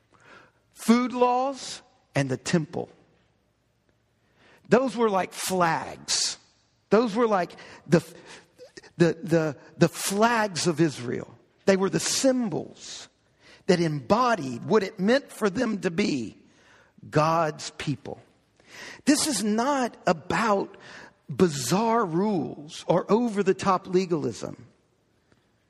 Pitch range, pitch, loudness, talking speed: 160-230 Hz, 190 Hz, -25 LUFS, 105 wpm